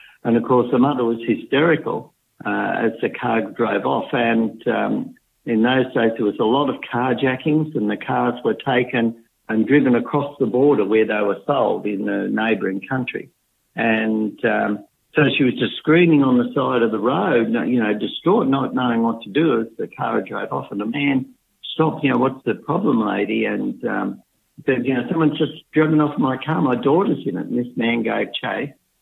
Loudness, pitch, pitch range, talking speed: -20 LUFS, 125 Hz, 115-145 Hz, 205 wpm